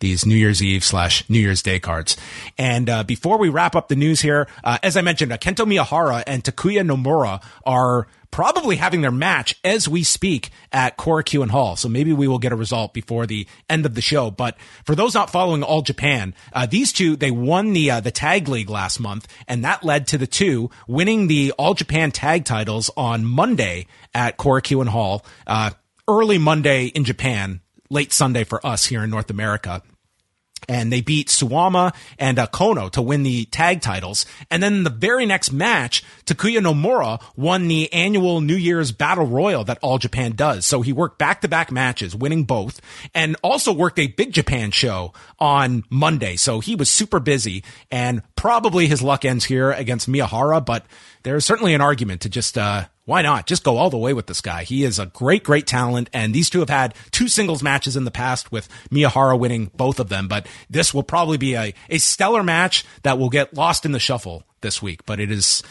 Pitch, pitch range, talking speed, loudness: 135 Hz, 115-160 Hz, 205 wpm, -19 LUFS